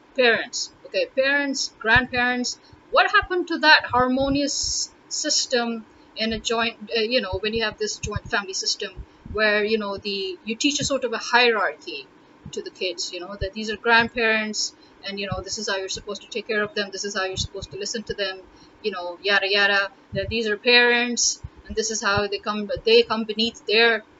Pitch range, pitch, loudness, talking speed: 205-290 Hz, 230 Hz, -22 LUFS, 210 wpm